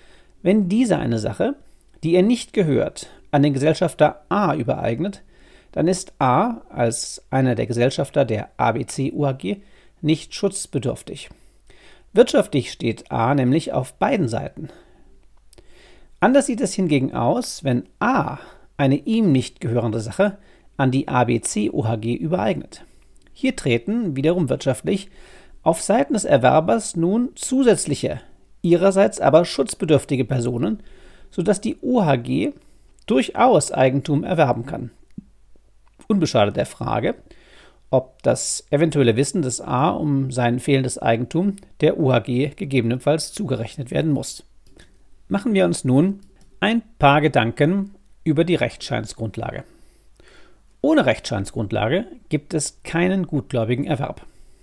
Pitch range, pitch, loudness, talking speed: 130-190 Hz, 150 Hz, -20 LUFS, 115 wpm